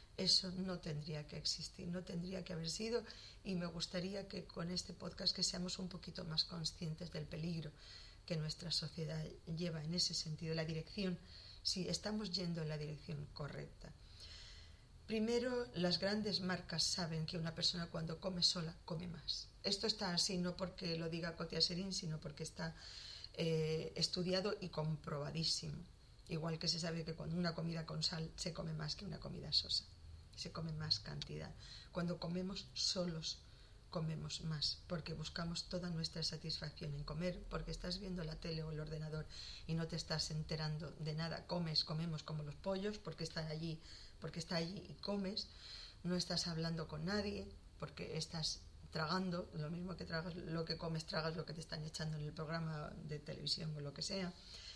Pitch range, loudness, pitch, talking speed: 155-180 Hz, -42 LUFS, 165 Hz, 175 wpm